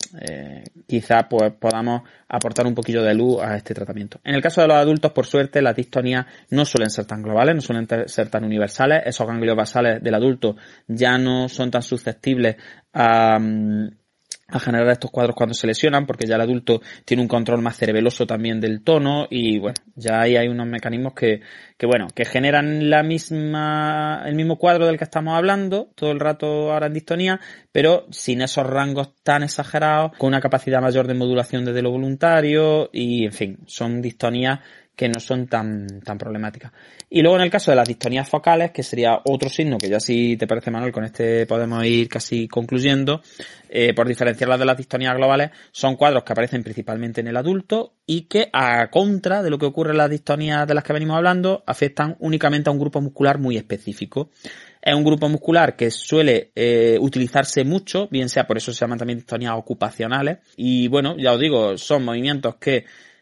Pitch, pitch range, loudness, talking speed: 125 Hz, 115-150 Hz, -20 LUFS, 195 wpm